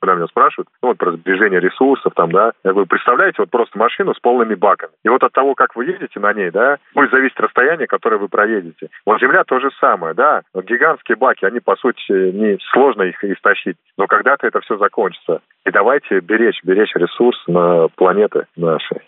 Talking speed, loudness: 200 wpm, -15 LUFS